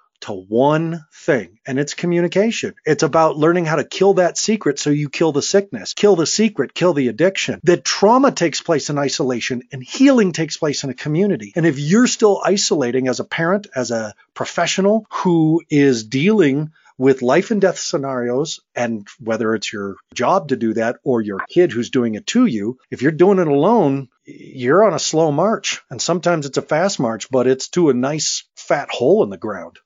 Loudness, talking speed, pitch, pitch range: -17 LUFS, 200 wpm, 155 Hz, 130-185 Hz